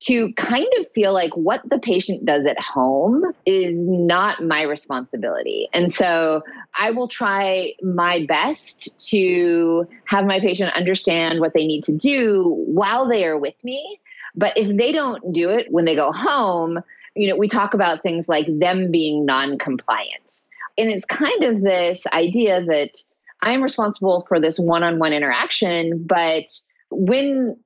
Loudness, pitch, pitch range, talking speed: -19 LUFS, 185 Hz, 165-220 Hz, 160 wpm